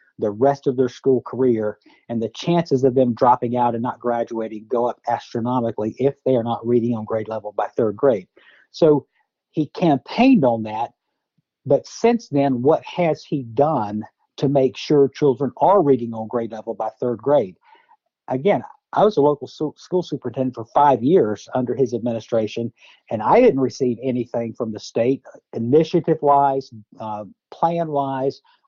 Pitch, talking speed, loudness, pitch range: 125 Hz, 170 wpm, -20 LUFS, 115-140 Hz